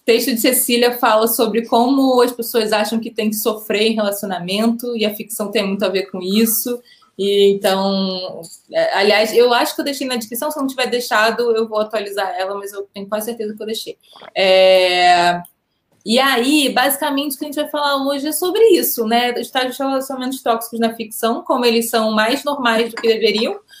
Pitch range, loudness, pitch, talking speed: 215-260 Hz, -16 LUFS, 230 Hz, 200 wpm